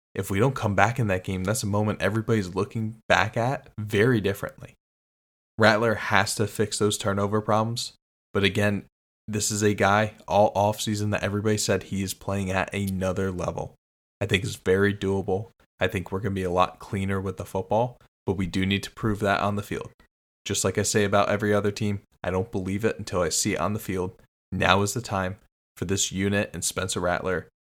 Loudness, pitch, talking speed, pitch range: -25 LUFS, 100 Hz, 210 wpm, 95-105 Hz